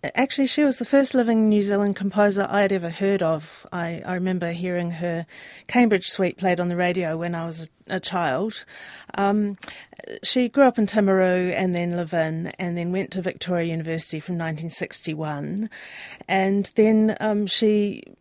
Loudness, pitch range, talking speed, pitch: -23 LUFS, 170-210 Hz, 170 wpm, 190 Hz